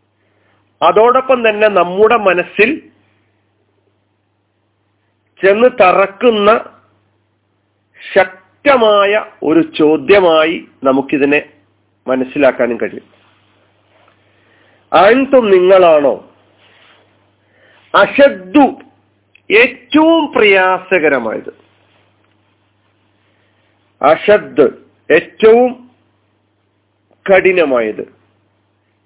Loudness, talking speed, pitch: -11 LUFS, 40 wpm, 110 Hz